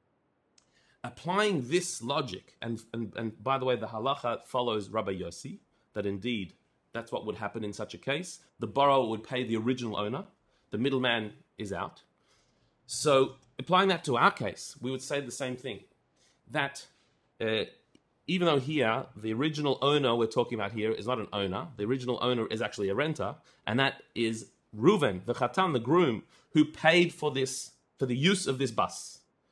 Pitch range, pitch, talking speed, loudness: 110-145 Hz, 125 Hz, 180 wpm, -30 LUFS